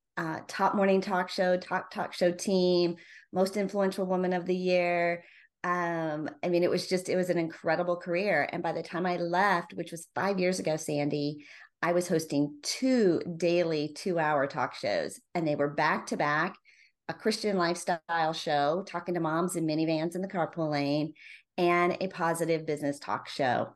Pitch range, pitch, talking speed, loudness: 160-180 Hz, 175 Hz, 180 wpm, -30 LUFS